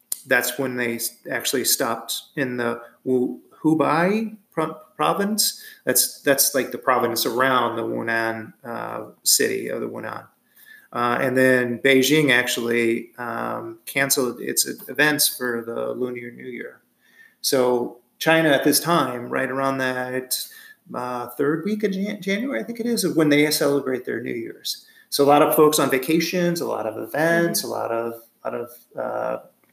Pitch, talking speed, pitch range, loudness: 135 Hz, 160 wpm, 120-165 Hz, -21 LUFS